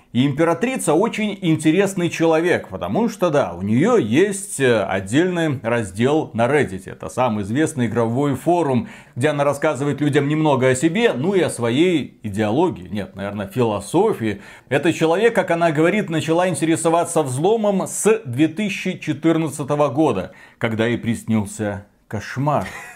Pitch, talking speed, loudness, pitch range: 150 Hz, 130 wpm, -19 LUFS, 120-170 Hz